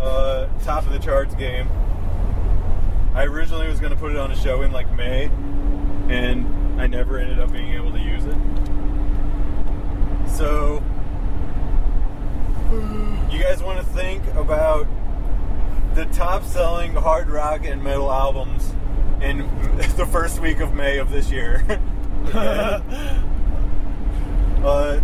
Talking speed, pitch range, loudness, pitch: 130 wpm, 80-130 Hz, -24 LUFS, 95 Hz